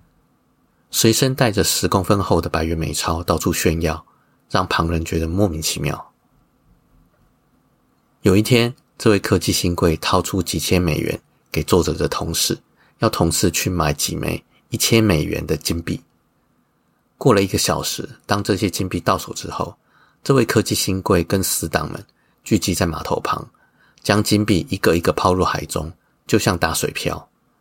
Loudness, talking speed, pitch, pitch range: -19 LUFS, 235 characters per minute, 95 Hz, 85-105 Hz